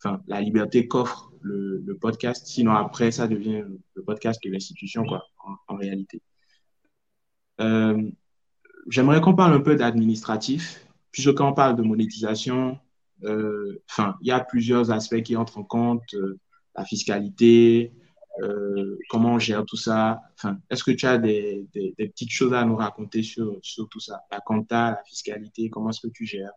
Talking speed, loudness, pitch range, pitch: 175 wpm, -23 LUFS, 105-120 Hz, 110 Hz